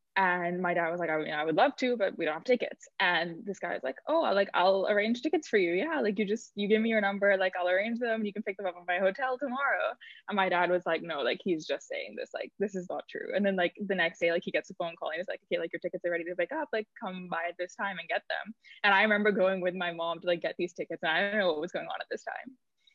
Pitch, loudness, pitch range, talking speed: 195 Hz, -30 LUFS, 175-220 Hz, 320 wpm